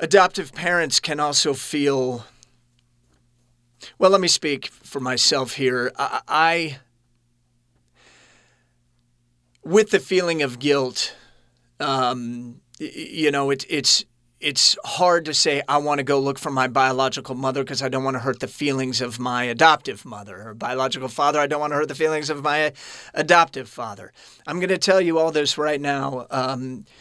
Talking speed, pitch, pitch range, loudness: 160 wpm, 135 Hz, 125-150 Hz, -21 LUFS